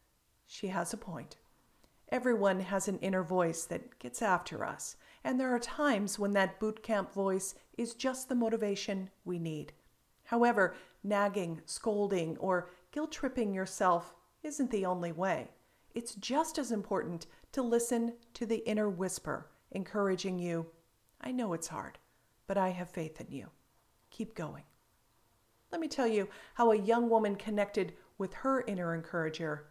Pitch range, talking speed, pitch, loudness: 180-235 Hz, 155 wpm, 200 Hz, -35 LUFS